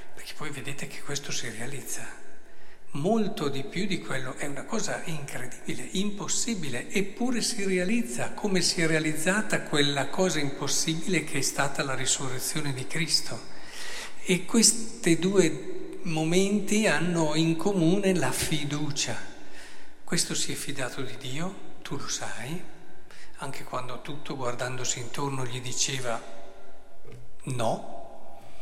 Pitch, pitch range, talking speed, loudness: 155 Hz, 135-185 Hz, 125 wpm, -28 LUFS